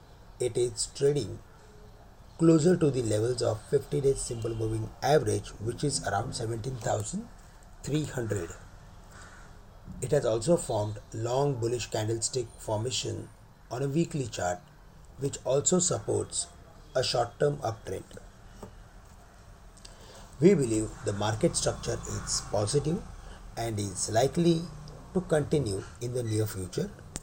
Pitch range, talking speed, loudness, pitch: 100-140 Hz, 115 wpm, -29 LUFS, 115 Hz